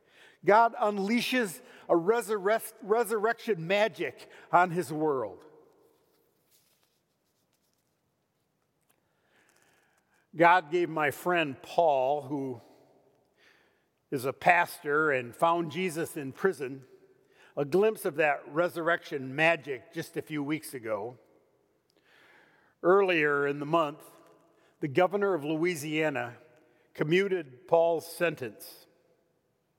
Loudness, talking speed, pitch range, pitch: -28 LUFS, 90 wpm, 155-220 Hz, 170 Hz